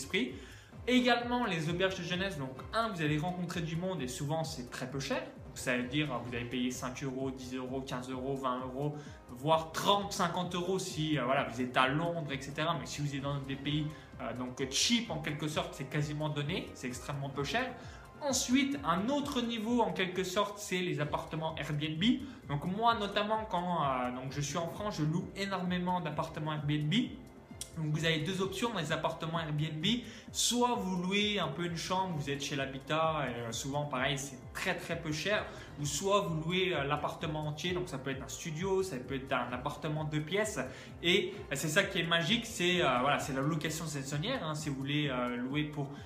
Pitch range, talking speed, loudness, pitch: 135-185 Hz, 200 wpm, -34 LUFS, 155 Hz